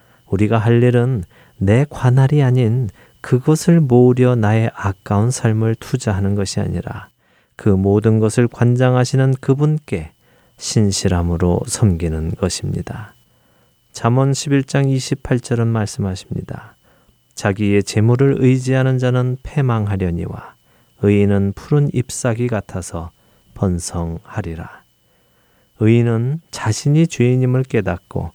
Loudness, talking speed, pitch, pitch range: -17 LUFS, 250 characters per minute, 115 Hz, 100-130 Hz